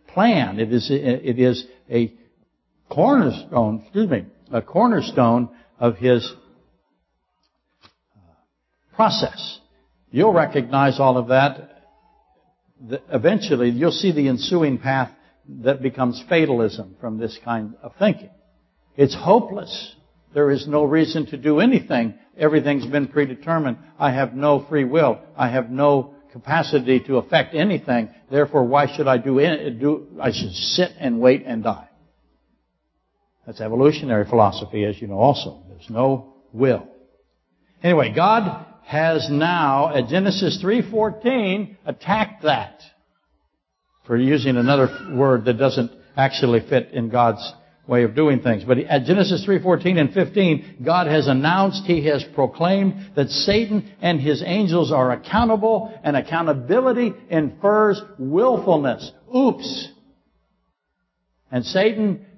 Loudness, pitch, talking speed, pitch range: -19 LUFS, 140 Hz, 125 wpm, 120-170 Hz